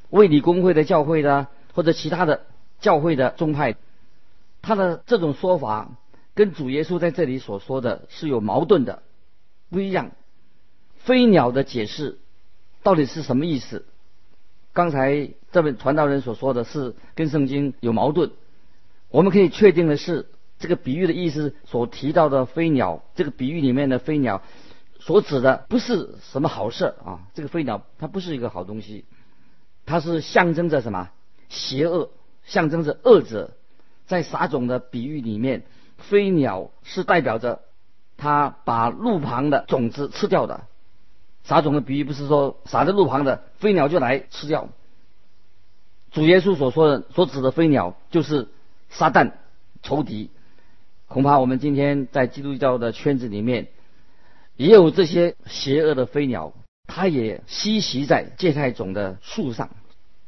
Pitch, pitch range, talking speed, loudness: 145 Hz, 125-170 Hz, 230 characters per minute, -21 LUFS